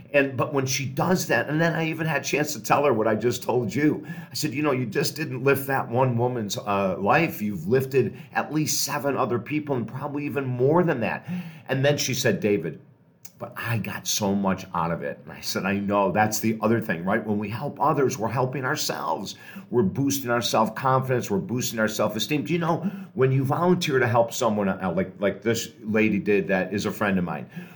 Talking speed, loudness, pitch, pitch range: 235 wpm, -24 LUFS, 130 Hz, 110-150 Hz